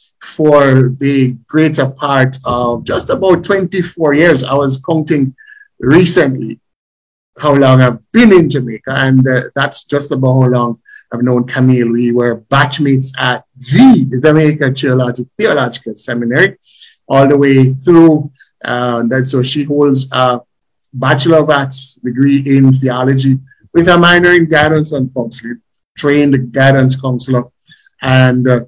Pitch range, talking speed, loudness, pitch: 125-150 Hz, 140 wpm, -11 LUFS, 135 Hz